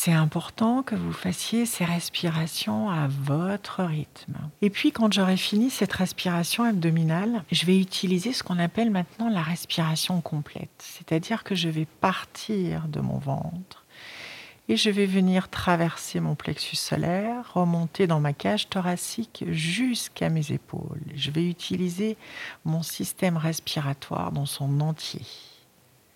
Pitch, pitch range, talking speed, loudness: 175 Hz, 160-200 Hz, 140 wpm, -26 LUFS